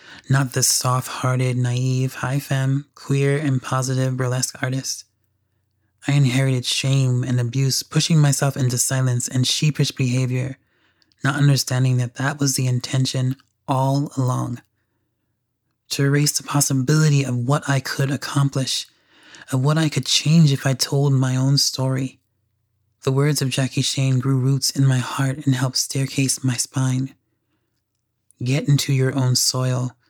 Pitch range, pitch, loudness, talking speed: 125-140 Hz, 130 Hz, -20 LUFS, 145 wpm